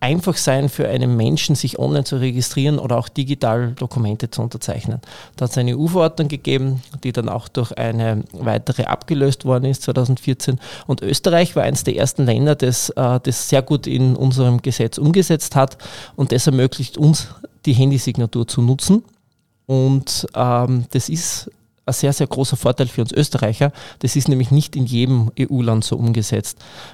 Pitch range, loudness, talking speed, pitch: 120-140 Hz, -18 LUFS, 165 wpm, 130 Hz